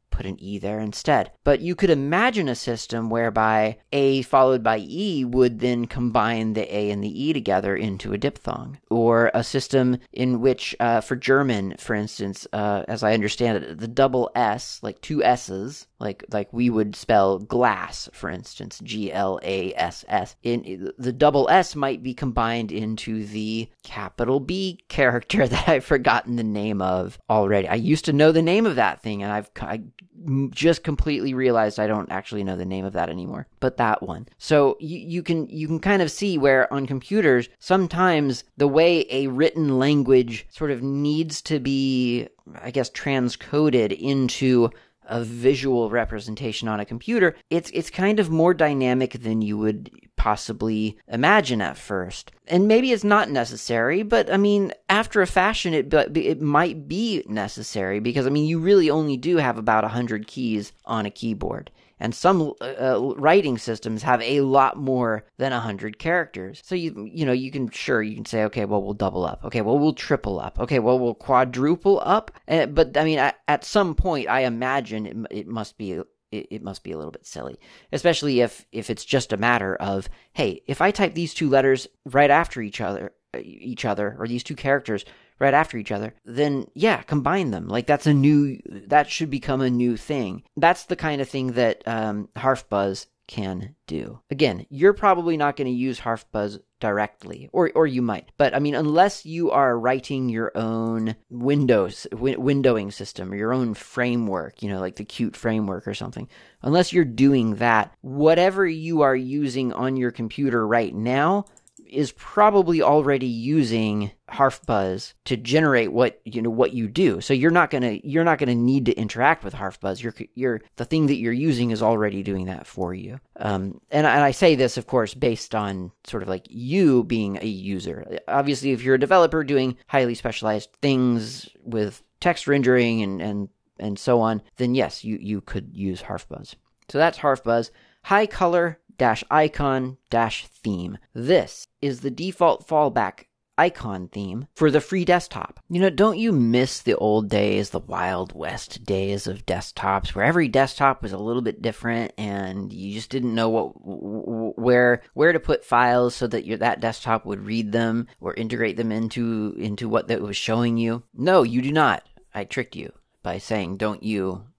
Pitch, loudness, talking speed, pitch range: 120 Hz, -22 LUFS, 185 wpm, 110-145 Hz